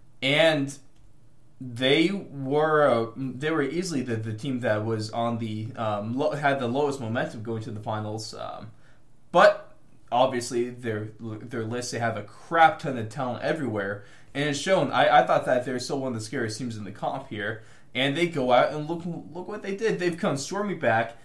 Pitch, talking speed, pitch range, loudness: 125 Hz, 200 wpm, 115-145 Hz, -26 LUFS